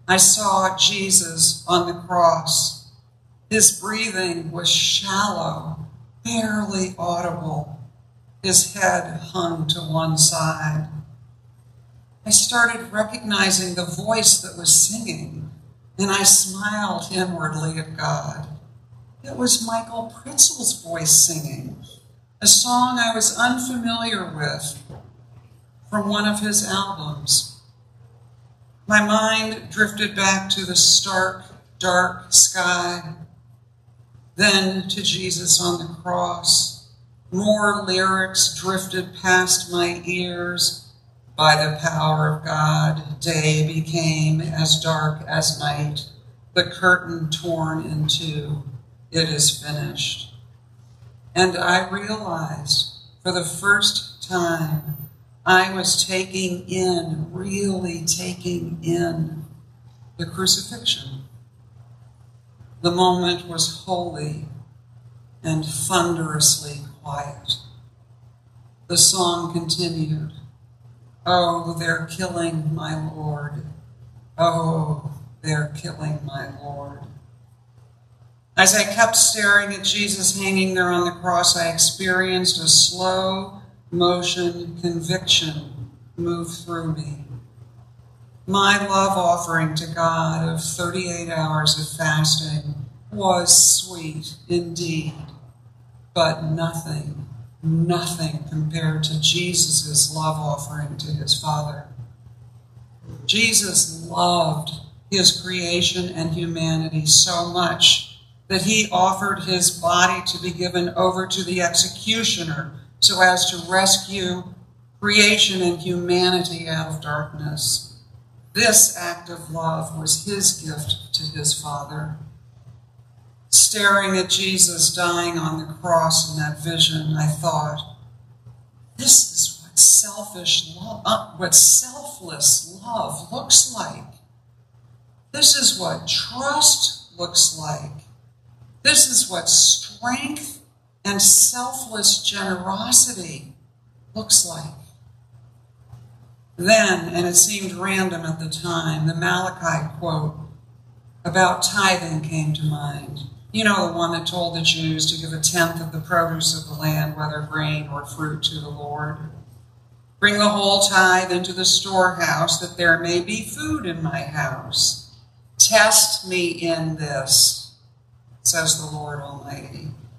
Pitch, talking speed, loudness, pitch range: 160 Hz, 110 wpm, -18 LUFS, 135-180 Hz